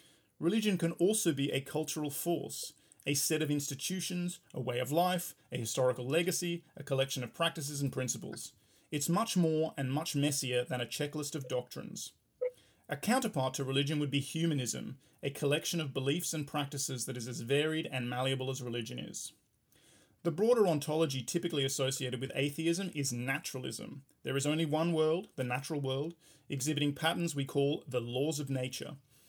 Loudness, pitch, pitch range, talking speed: -34 LUFS, 145 Hz, 135-165 Hz, 170 wpm